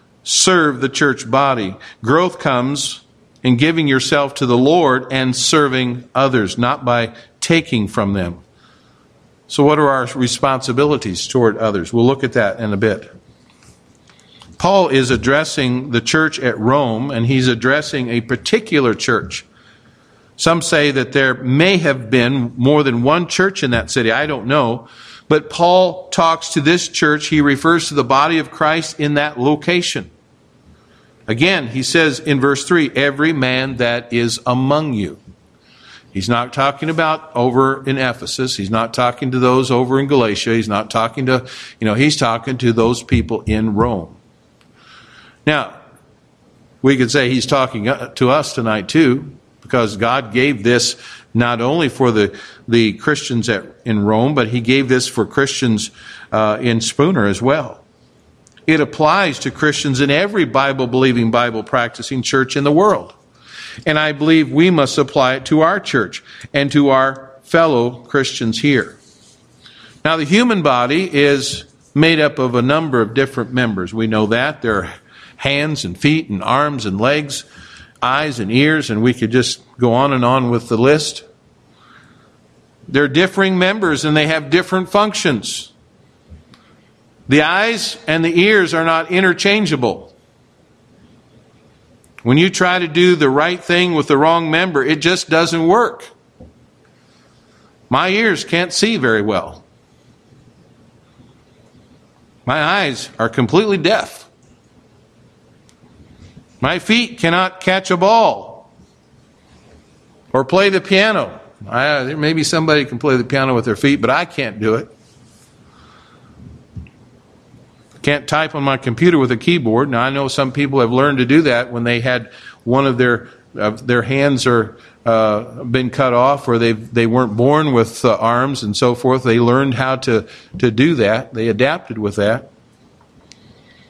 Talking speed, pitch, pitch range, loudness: 155 wpm, 135 Hz, 120-150 Hz, -15 LUFS